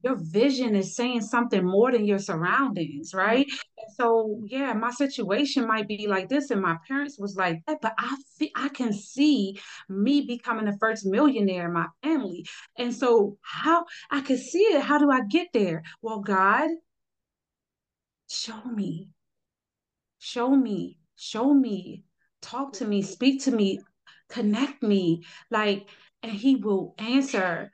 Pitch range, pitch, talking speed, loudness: 195-270 Hz, 225 Hz, 155 wpm, -25 LUFS